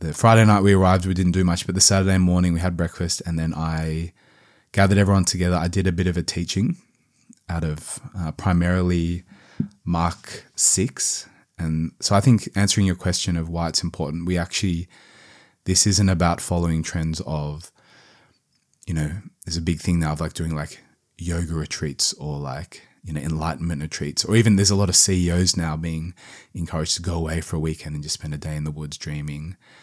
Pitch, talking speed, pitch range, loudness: 85 Hz, 195 wpm, 80-95 Hz, -21 LUFS